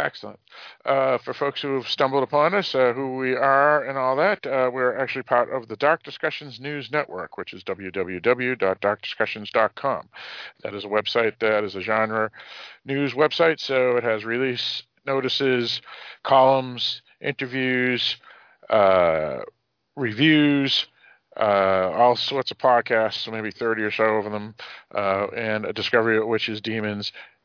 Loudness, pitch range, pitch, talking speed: -22 LUFS, 110-135 Hz, 125 Hz, 145 wpm